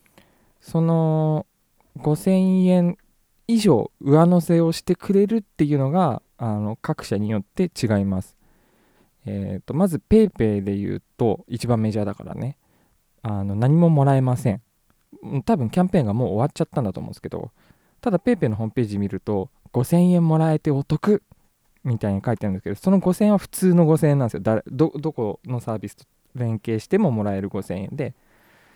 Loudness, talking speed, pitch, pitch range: -21 LUFS, 345 characters per minute, 140 Hz, 110-170 Hz